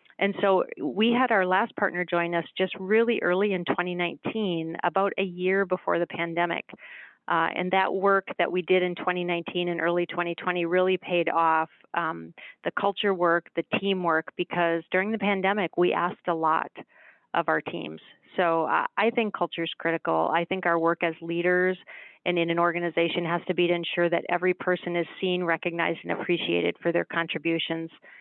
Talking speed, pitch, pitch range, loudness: 180 wpm, 175 Hz, 170-185 Hz, -26 LUFS